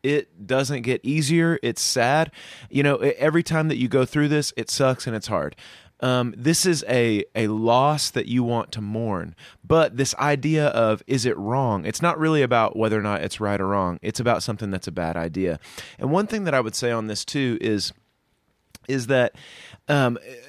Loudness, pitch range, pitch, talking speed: -23 LUFS, 110-145 Hz, 125 Hz, 205 wpm